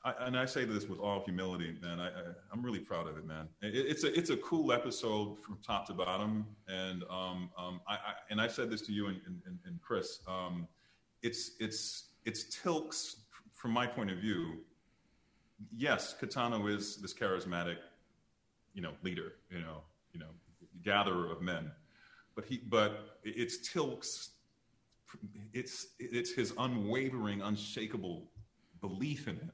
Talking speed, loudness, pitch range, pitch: 165 wpm, -38 LUFS, 90-120 Hz, 105 Hz